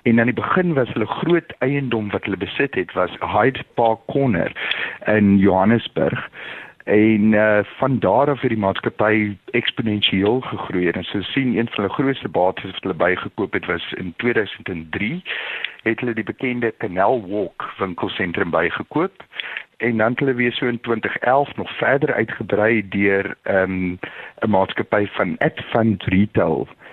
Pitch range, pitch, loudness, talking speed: 100-125 Hz, 110 Hz, -20 LUFS, 160 wpm